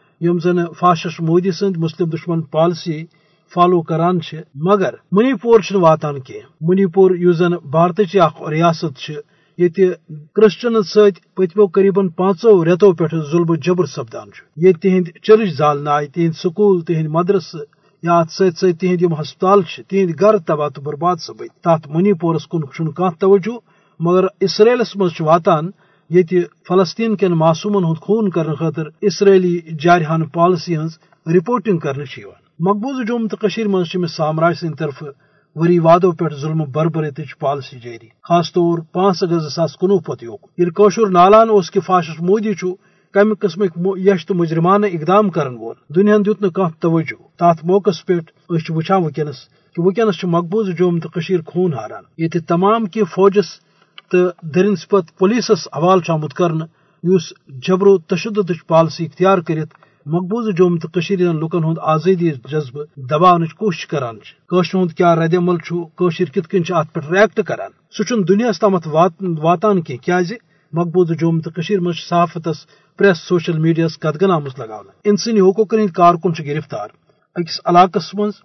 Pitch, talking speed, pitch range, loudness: 175 Hz, 145 wpm, 165-195 Hz, -16 LUFS